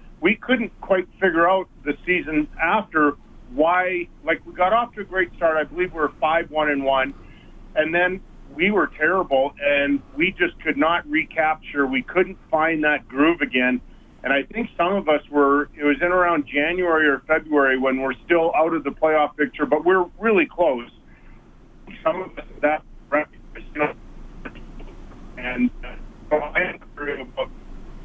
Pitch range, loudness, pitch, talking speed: 145-180 Hz, -21 LUFS, 155 Hz, 160 wpm